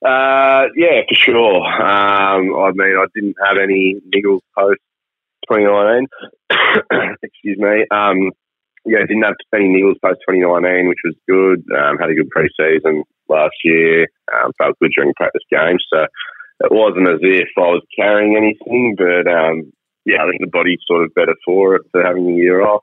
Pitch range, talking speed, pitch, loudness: 90-105 Hz, 180 wpm, 95 Hz, -13 LUFS